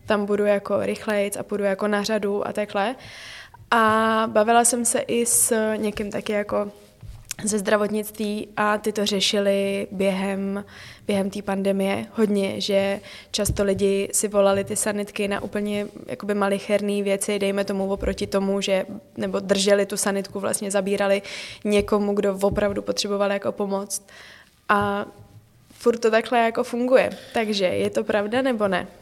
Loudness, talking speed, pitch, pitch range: -23 LUFS, 150 wpm, 205 Hz, 195-210 Hz